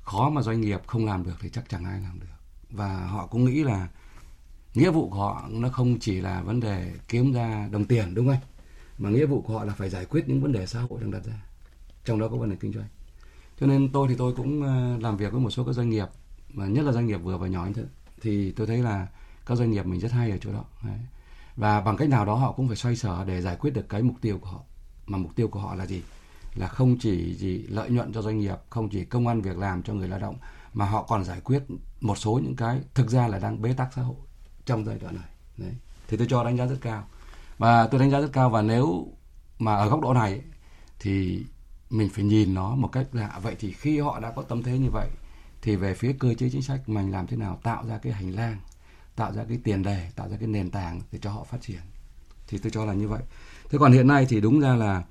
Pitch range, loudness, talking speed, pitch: 95-120 Hz, -26 LUFS, 265 wpm, 110 Hz